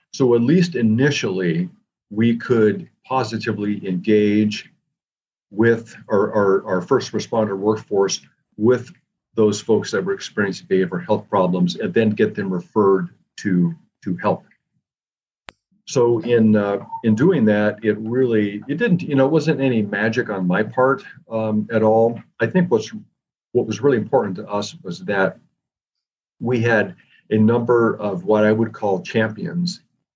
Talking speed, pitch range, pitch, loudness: 150 wpm, 105-125 Hz, 110 Hz, -19 LUFS